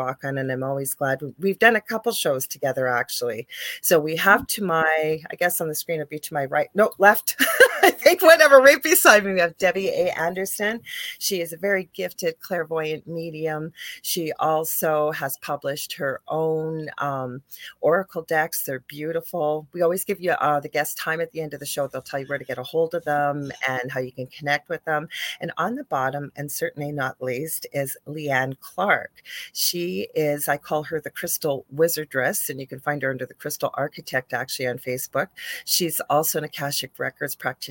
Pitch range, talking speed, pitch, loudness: 140-180 Hz, 200 wpm, 155 Hz, -22 LUFS